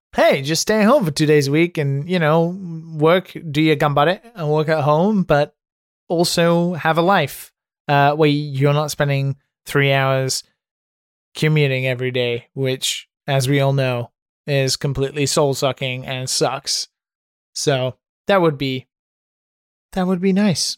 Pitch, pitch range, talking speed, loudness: 150 Hz, 135-165 Hz, 155 wpm, -18 LUFS